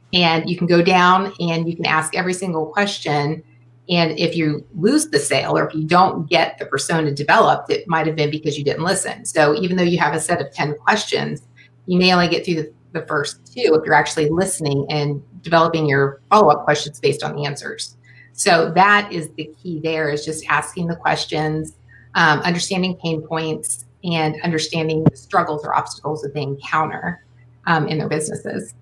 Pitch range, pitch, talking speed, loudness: 150-175 Hz, 155 Hz, 195 wpm, -18 LUFS